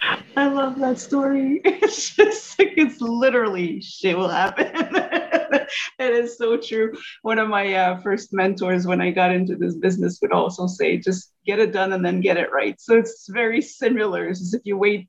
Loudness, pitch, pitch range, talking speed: -21 LUFS, 225 Hz, 190-275 Hz, 190 wpm